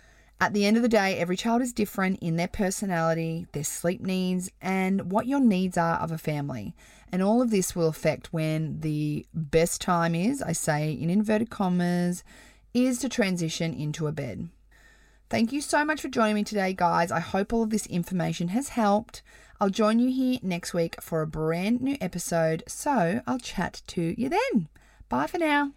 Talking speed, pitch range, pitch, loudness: 195 wpm, 165-225 Hz, 185 Hz, -27 LUFS